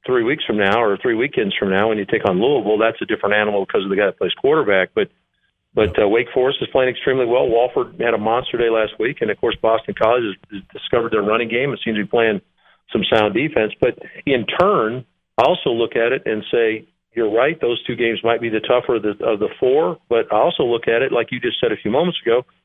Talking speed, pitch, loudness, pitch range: 255 wpm, 115 Hz, -18 LUFS, 110-130 Hz